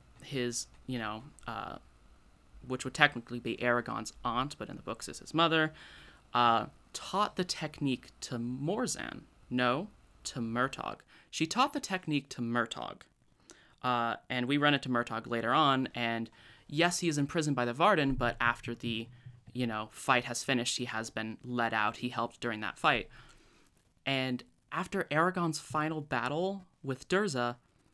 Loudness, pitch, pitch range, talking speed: -33 LUFS, 125 Hz, 120-150 Hz, 160 wpm